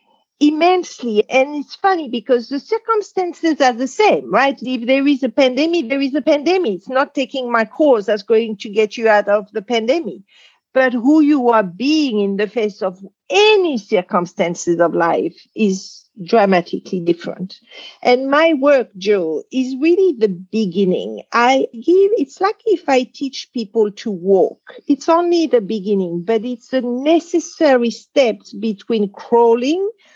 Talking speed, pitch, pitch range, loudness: 155 wpm, 250 Hz, 215-295 Hz, -16 LUFS